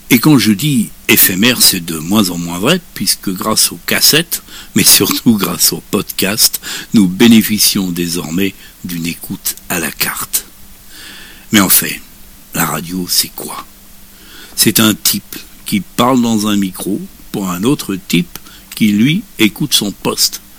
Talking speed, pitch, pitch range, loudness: 150 wpm, 105 Hz, 90-120 Hz, -12 LUFS